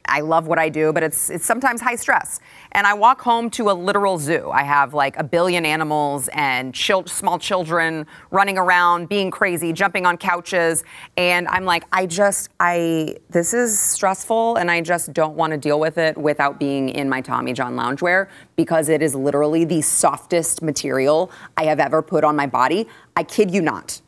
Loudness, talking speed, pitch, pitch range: -19 LUFS, 195 wpm, 170 Hz, 155-190 Hz